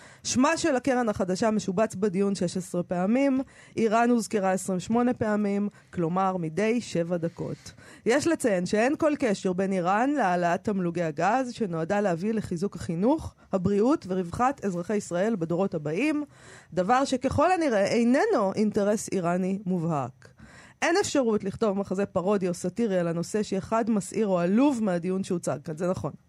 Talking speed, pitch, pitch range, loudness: 140 wpm, 200 Hz, 180-235 Hz, -26 LUFS